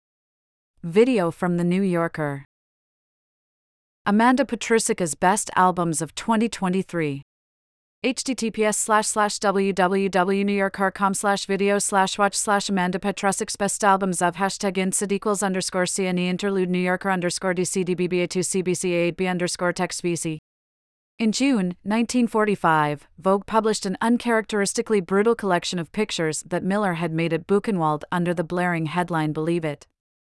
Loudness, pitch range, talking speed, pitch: -22 LUFS, 175-205 Hz, 120 wpm, 190 Hz